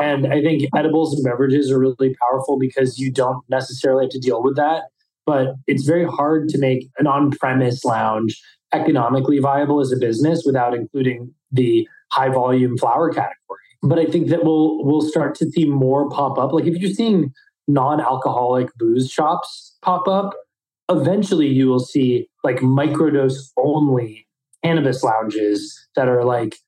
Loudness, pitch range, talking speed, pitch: -18 LUFS, 130-155 Hz, 160 wpm, 135 Hz